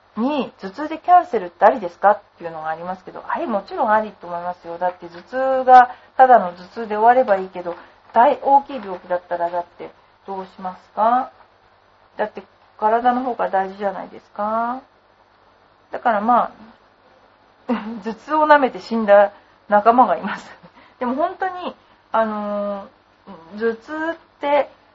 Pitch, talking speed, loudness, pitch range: 220 Hz, 310 characters per minute, -19 LUFS, 190-255 Hz